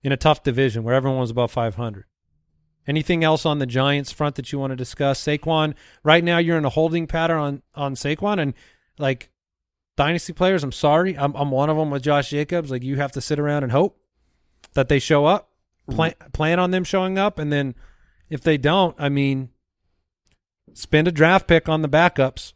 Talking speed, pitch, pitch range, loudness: 205 wpm, 145 Hz, 130-160 Hz, -21 LUFS